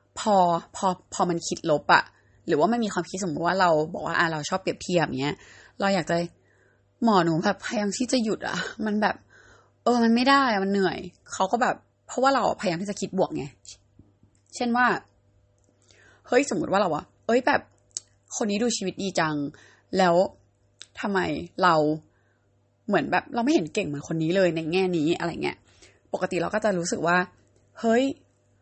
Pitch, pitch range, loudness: 180 Hz, 140-210 Hz, -25 LUFS